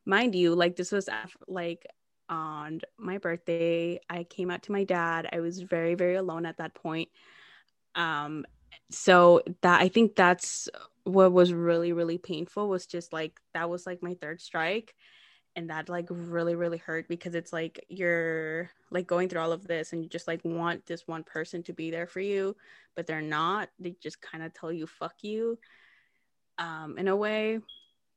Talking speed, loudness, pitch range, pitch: 185 wpm, -29 LUFS, 165-180 Hz, 170 Hz